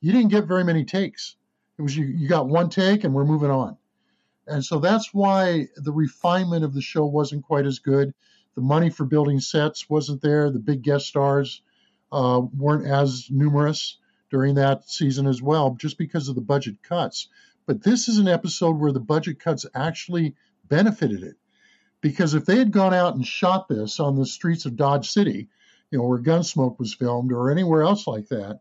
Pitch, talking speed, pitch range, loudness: 150 Hz, 195 wpm, 140-175 Hz, -22 LUFS